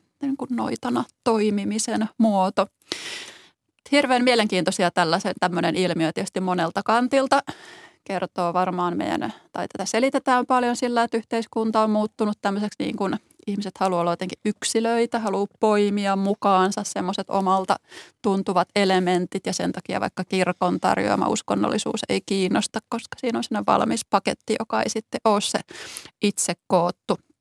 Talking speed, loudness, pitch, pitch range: 135 wpm, -23 LUFS, 205 Hz, 185-230 Hz